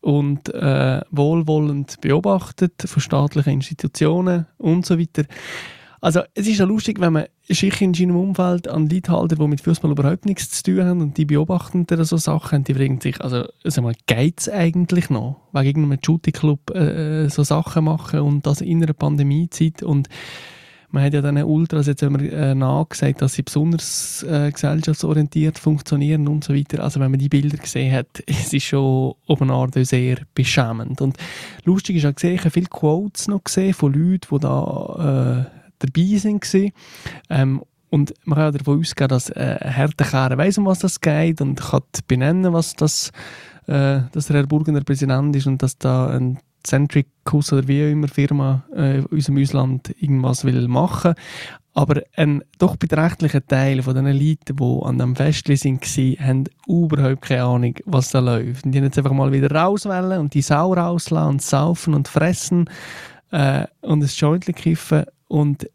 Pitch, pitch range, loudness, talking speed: 150 Hz, 140-165 Hz, -19 LUFS, 185 wpm